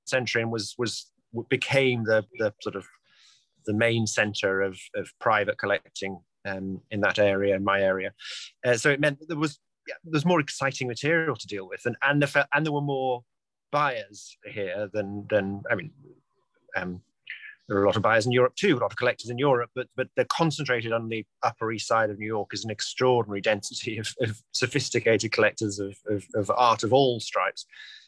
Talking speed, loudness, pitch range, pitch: 205 wpm, -26 LUFS, 105-135 Hz, 115 Hz